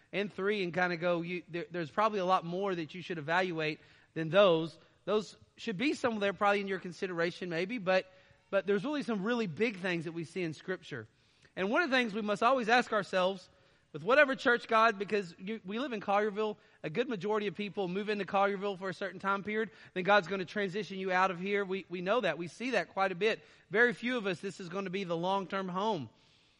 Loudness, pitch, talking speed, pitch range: -32 LUFS, 195 Hz, 245 wpm, 180-215 Hz